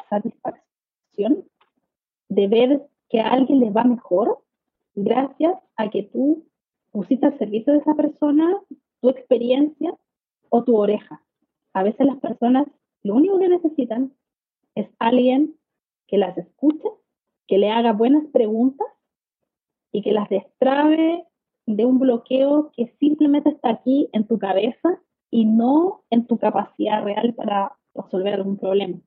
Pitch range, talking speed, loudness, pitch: 215-295 Hz, 135 wpm, -20 LUFS, 250 Hz